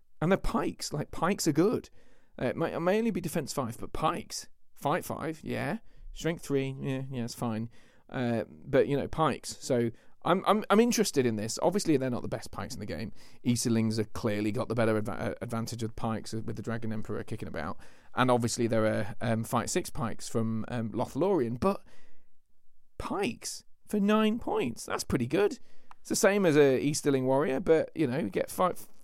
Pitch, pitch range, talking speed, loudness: 120 Hz, 110-160 Hz, 200 wpm, -30 LUFS